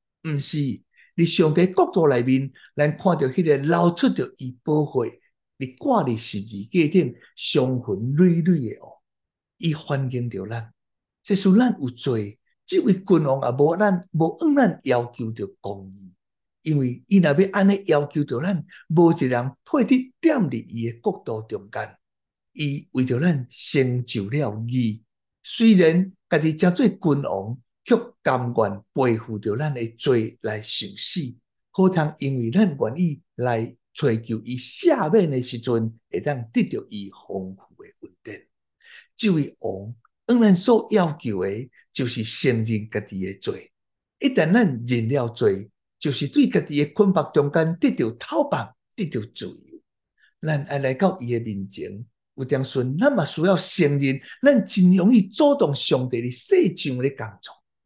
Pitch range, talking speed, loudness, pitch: 120-185 Hz, 215 characters per minute, -22 LUFS, 145 Hz